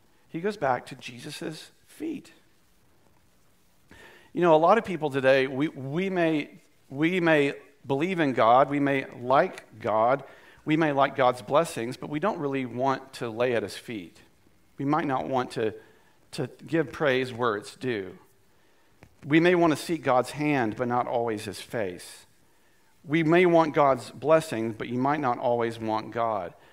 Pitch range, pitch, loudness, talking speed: 125-160 Hz, 140 Hz, -26 LUFS, 170 wpm